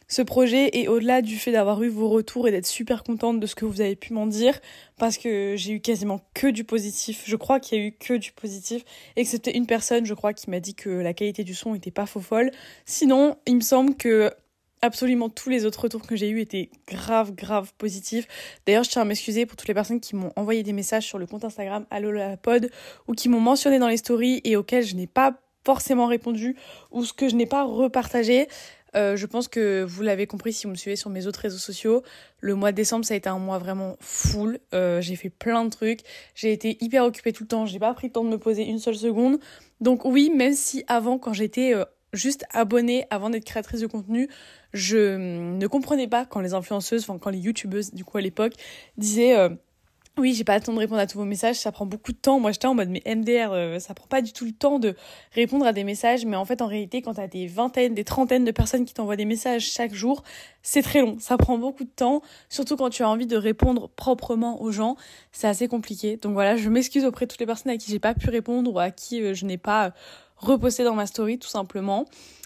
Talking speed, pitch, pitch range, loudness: 250 wpm, 225 Hz, 210-245 Hz, -24 LUFS